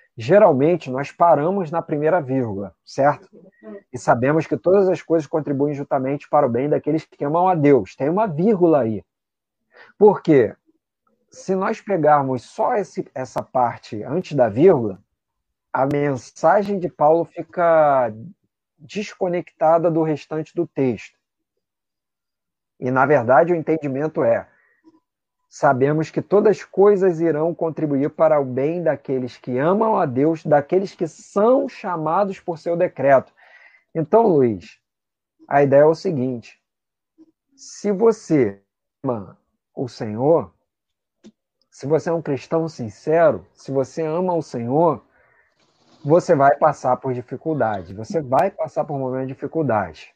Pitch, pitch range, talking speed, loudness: 155 Hz, 135-180 Hz, 135 wpm, -19 LUFS